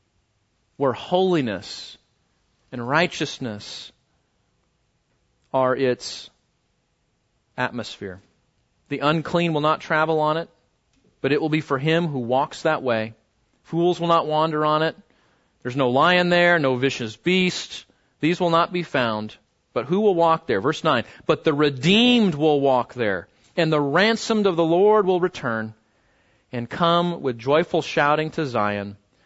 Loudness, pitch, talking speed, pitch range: -21 LUFS, 150 Hz, 145 wpm, 120-170 Hz